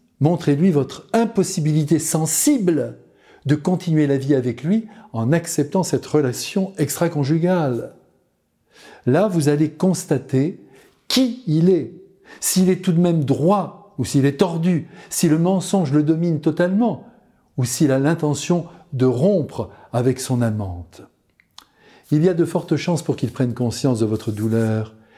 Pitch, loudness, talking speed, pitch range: 155 Hz, -19 LUFS, 145 wpm, 135-185 Hz